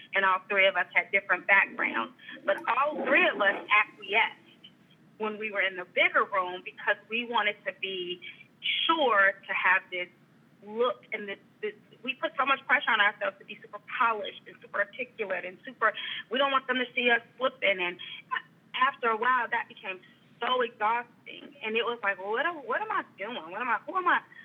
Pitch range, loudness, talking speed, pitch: 195-255 Hz, -28 LUFS, 200 wpm, 215 Hz